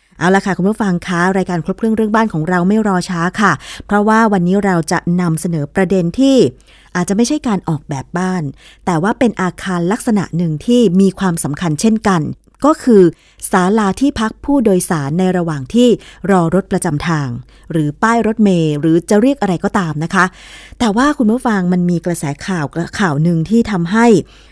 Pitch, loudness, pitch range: 185 Hz, -14 LUFS, 170-215 Hz